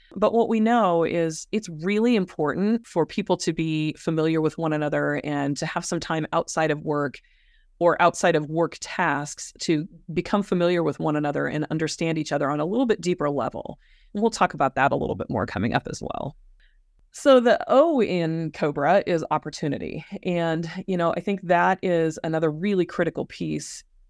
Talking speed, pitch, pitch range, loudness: 190 wpm, 165 Hz, 155-190 Hz, -24 LUFS